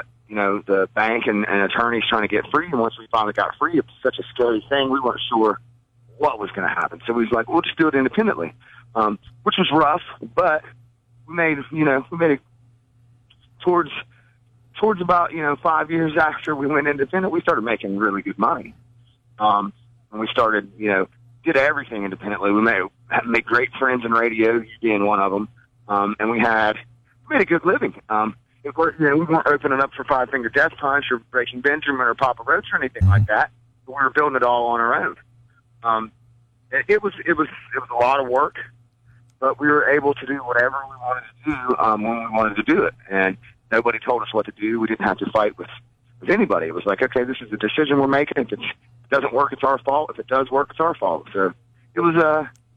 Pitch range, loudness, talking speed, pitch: 115-140 Hz, -20 LUFS, 235 wpm, 120 Hz